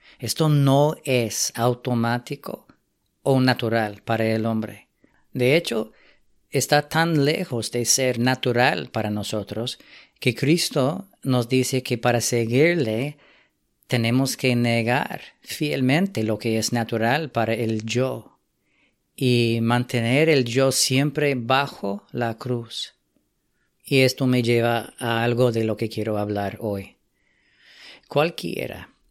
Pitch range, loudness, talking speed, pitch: 115-135 Hz, -22 LUFS, 120 wpm, 120 Hz